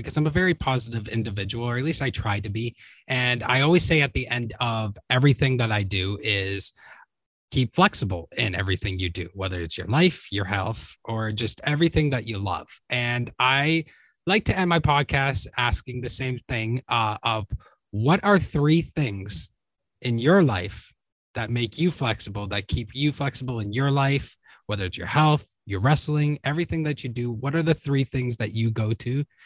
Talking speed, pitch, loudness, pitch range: 190 wpm, 120 Hz, -24 LUFS, 105-145 Hz